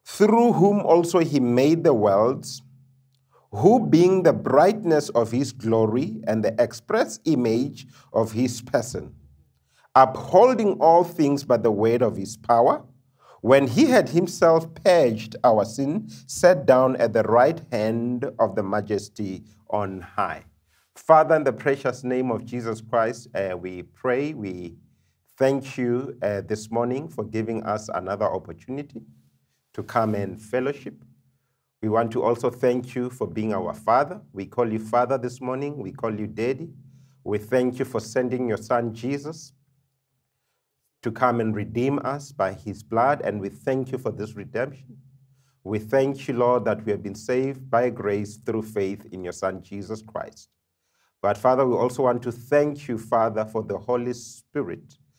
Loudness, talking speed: -23 LUFS, 160 wpm